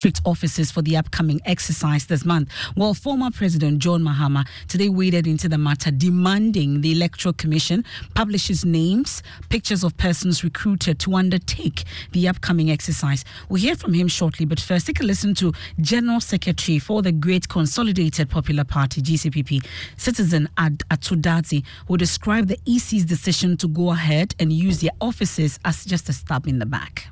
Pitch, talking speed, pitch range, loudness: 170 Hz, 165 wpm, 155-185 Hz, -21 LUFS